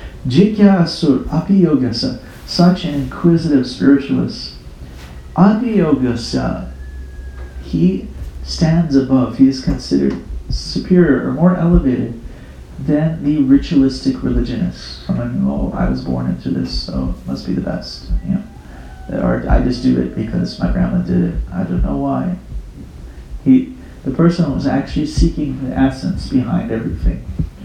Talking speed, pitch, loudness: 135 wpm, 125 Hz, -16 LUFS